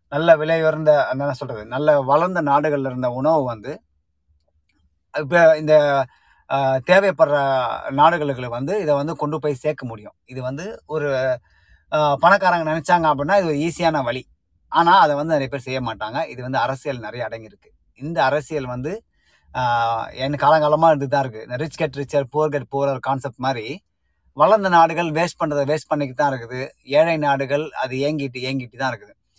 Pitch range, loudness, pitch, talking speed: 130-155 Hz, -19 LUFS, 140 Hz, 150 wpm